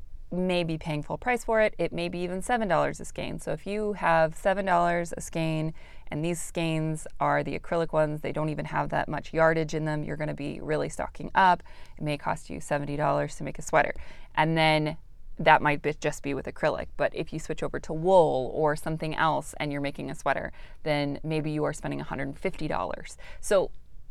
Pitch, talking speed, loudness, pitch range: 155 Hz, 225 wpm, -28 LUFS, 150-170 Hz